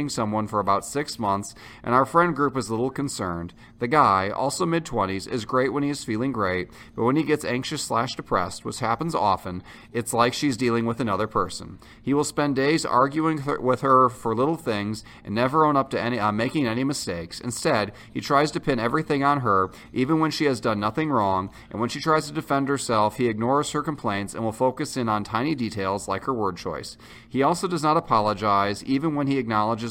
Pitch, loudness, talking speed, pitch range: 125 Hz, -24 LUFS, 220 wpm, 110-145 Hz